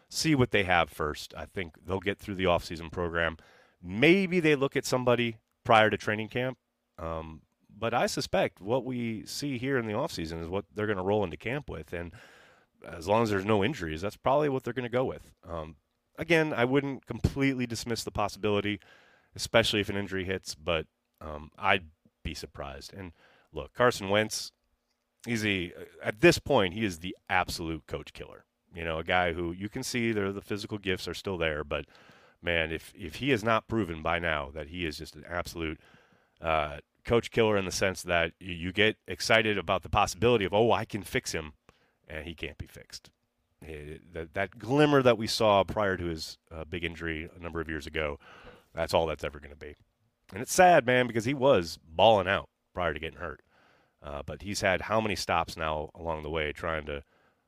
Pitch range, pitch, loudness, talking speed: 85-115 Hz, 100 Hz, -29 LUFS, 205 wpm